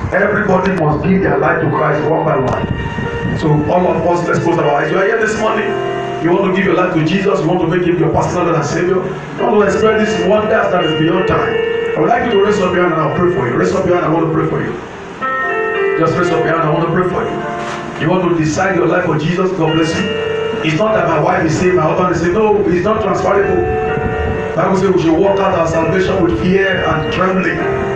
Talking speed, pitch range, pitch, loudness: 275 wpm, 165-200 Hz, 180 Hz, -14 LUFS